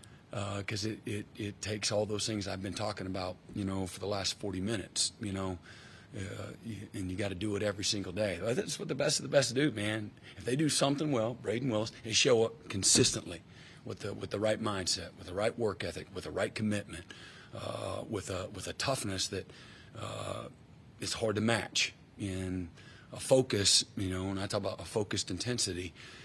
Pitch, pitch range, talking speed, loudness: 105 Hz, 95-115 Hz, 215 wpm, -33 LUFS